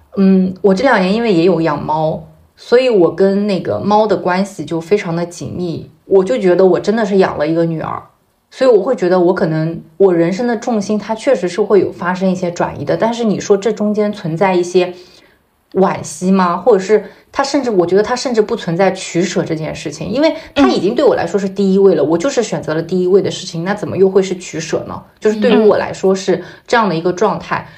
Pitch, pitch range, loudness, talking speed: 190 Hz, 175-210 Hz, -14 LUFS, 335 characters per minute